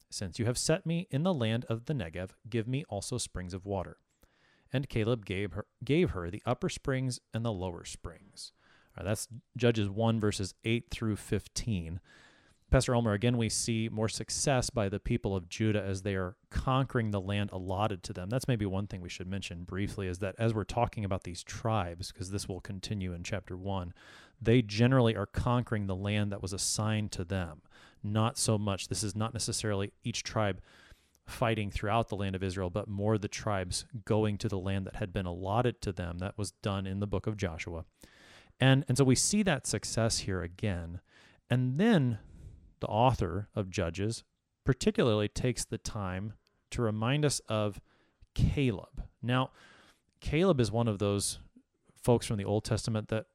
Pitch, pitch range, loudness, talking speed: 105 Hz, 95-115 Hz, -32 LUFS, 185 wpm